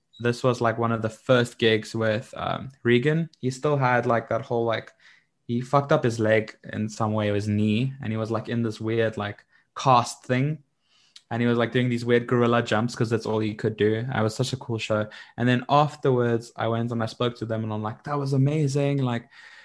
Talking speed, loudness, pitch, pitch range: 230 wpm, -25 LUFS, 120 Hz, 110-130 Hz